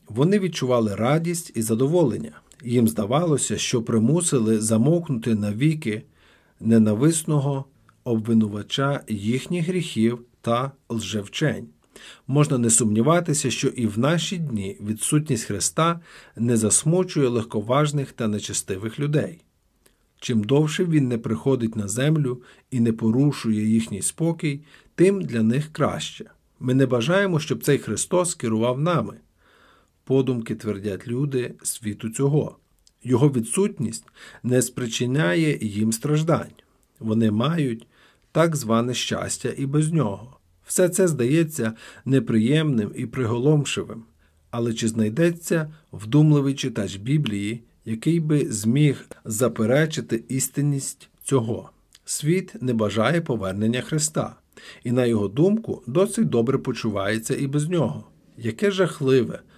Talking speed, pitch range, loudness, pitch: 115 wpm, 110-150 Hz, -23 LUFS, 125 Hz